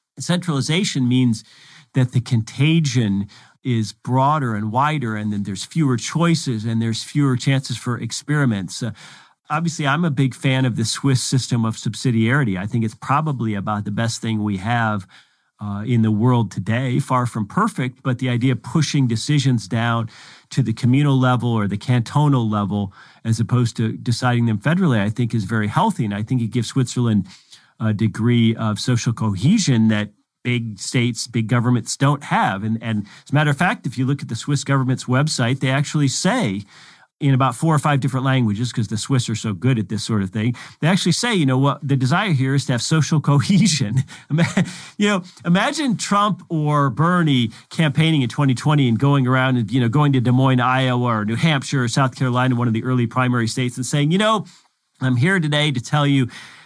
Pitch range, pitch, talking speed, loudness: 115-145 Hz, 130 Hz, 195 wpm, -19 LUFS